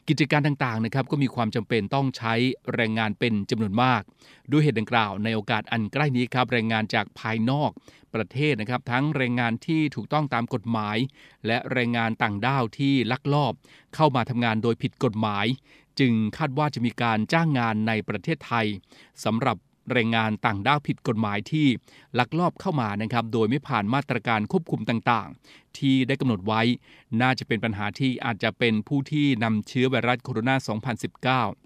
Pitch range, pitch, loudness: 115-140 Hz, 120 Hz, -25 LUFS